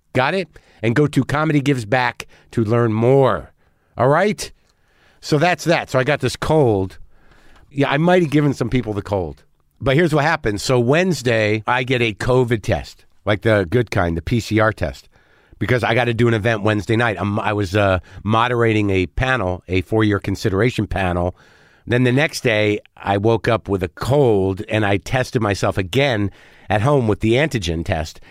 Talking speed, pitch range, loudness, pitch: 190 wpm, 100-130 Hz, -18 LUFS, 115 Hz